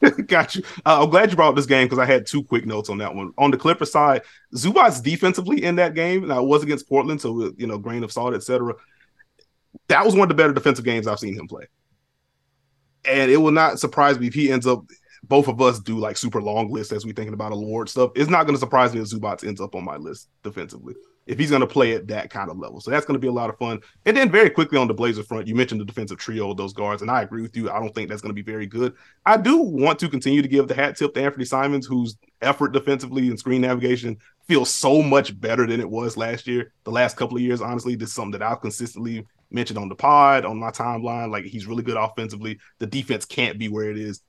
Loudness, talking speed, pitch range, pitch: -20 LUFS, 265 wpm, 110-135 Hz, 120 Hz